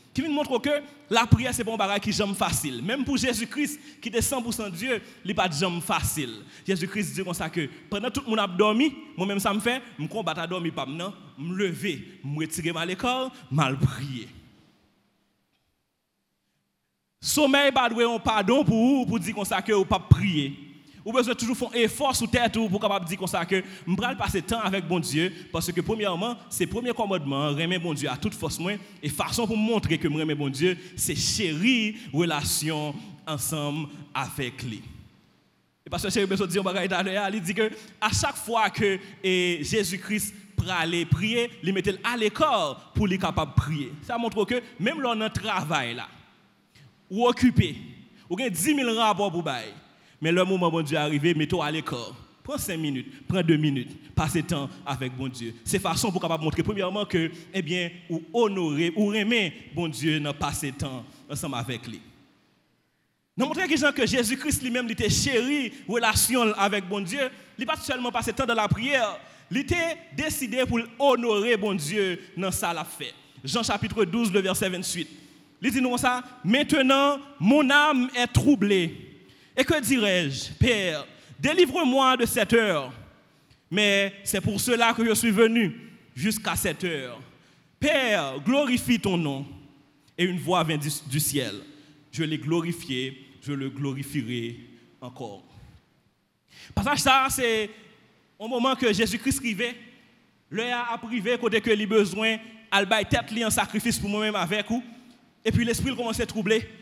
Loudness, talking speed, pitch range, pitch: -25 LUFS, 180 wpm, 165-235 Hz, 200 Hz